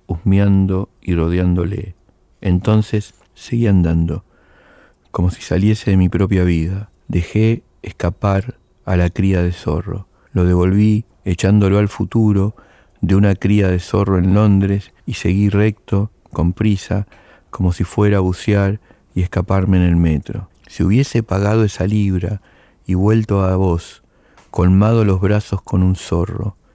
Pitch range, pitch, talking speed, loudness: 90-105 Hz, 95 Hz, 140 wpm, -17 LUFS